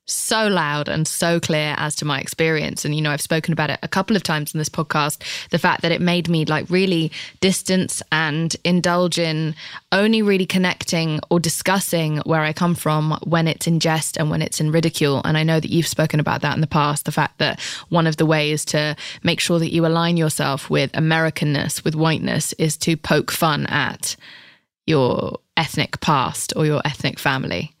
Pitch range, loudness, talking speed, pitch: 150-170 Hz, -19 LUFS, 205 wpm, 160 Hz